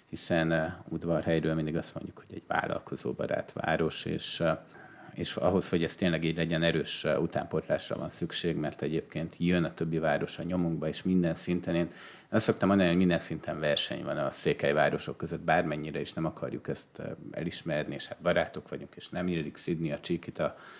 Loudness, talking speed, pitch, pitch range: -31 LUFS, 180 wpm, 85 Hz, 80-90 Hz